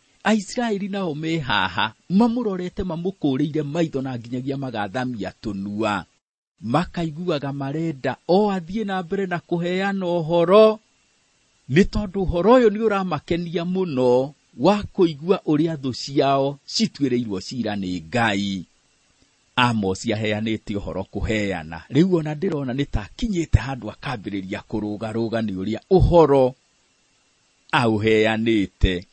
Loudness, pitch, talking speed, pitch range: -22 LUFS, 140 Hz, 105 wpm, 110-180 Hz